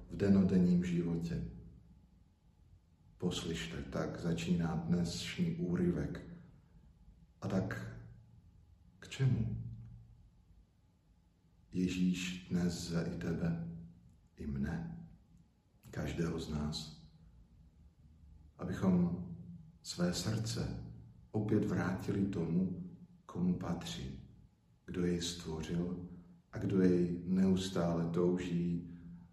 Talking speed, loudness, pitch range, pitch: 80 wpm, -36 LUFS, 85-95 Hz, 90 Hz